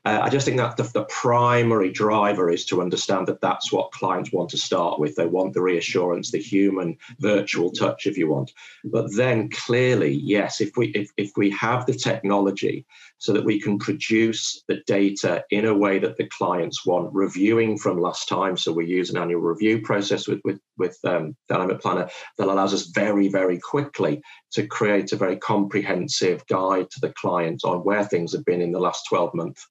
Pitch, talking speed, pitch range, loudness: 100 Hz, 200 wpm, 95-110 Hz, -23 LUFS